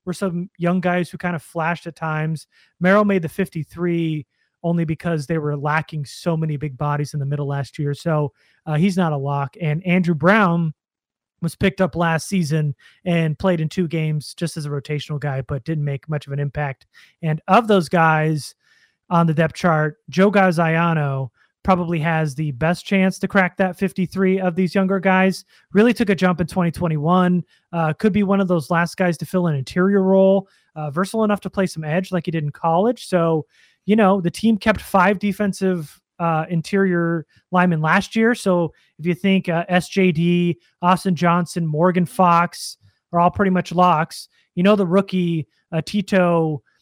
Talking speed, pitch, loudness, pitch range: 190 wpm, 170 Hz, -20 LUFS, 155-190 Hz